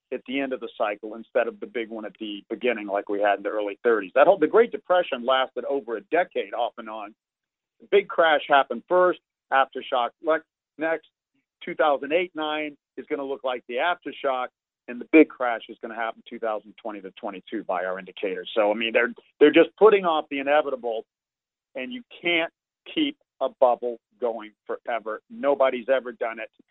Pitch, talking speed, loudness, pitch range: 135 Hz, 205 wpm, -24 LUFS, 115-165 Hz